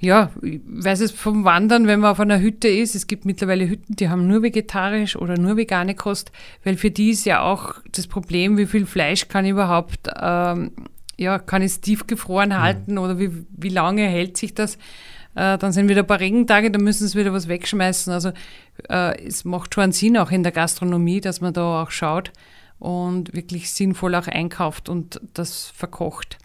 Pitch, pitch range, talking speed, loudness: 190 Hz, 180-210 Hz, 200 wpm, -20 LUFS